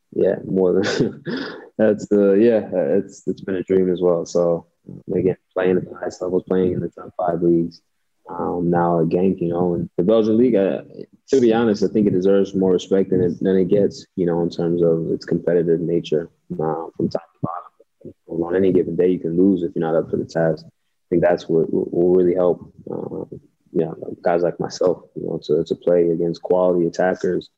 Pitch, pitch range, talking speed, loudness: 90 Hz, 85-95 Hz, 220 wpm, -20 LUFS